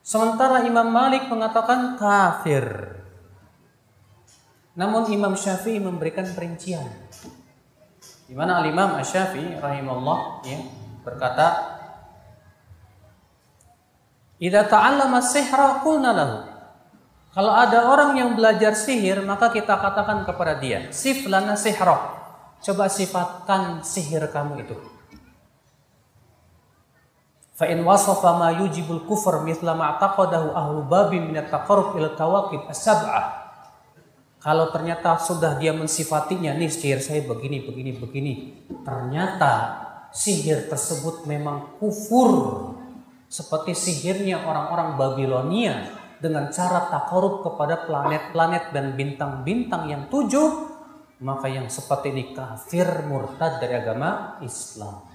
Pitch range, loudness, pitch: 140-200 Hz, -22 LUFS, 165 Hz